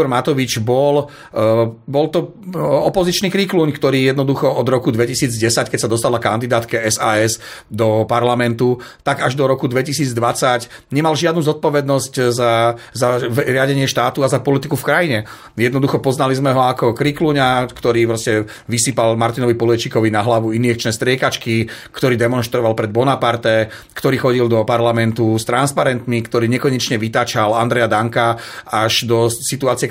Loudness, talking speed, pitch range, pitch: -16 LUFS, 140 wpm, 115-140 Hz, 120 Hz